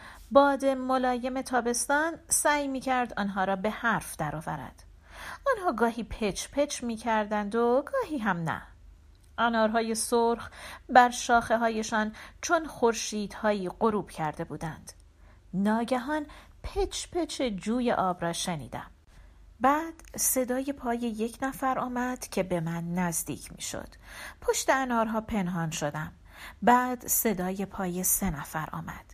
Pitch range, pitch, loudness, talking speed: 185-260 Hz, 230 Hz, -28 LUFS, 125 wpm